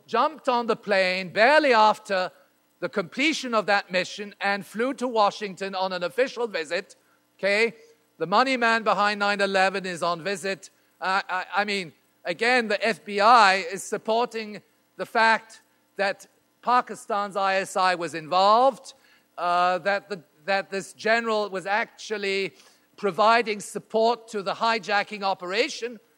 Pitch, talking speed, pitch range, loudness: 205 Hz, 135 wpm, 190-225 Hz, -24 LUFS